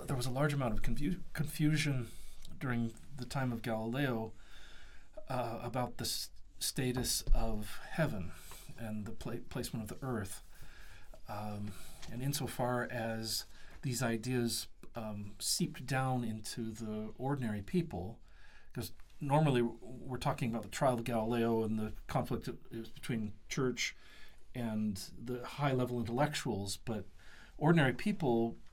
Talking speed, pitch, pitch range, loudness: 135 wpm, 120 Hz, 110-130 Hz, -37 LUFS